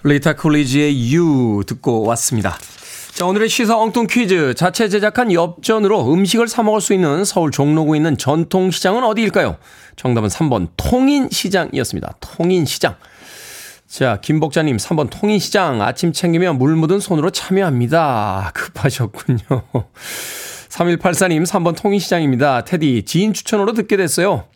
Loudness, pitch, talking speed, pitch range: -16 LUFS, 170 Hz, 315 characters per minute, 135-200 Hz